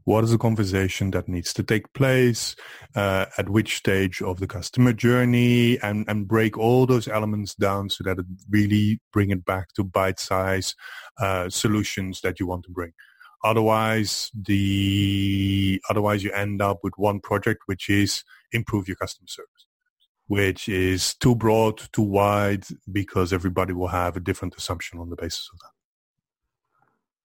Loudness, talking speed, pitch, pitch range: -23 LUFS, 165 wpm, 100 Hz, 95-110 Hz